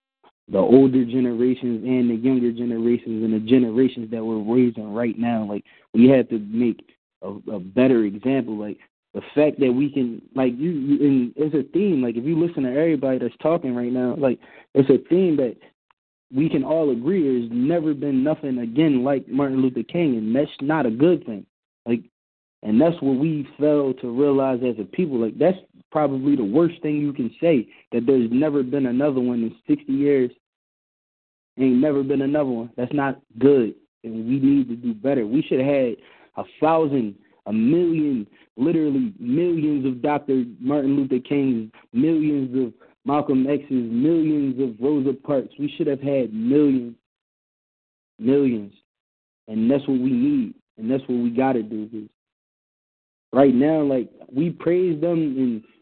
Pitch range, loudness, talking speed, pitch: 120-150 Hz, -21 LUFS, 175 wpm, 135 Hz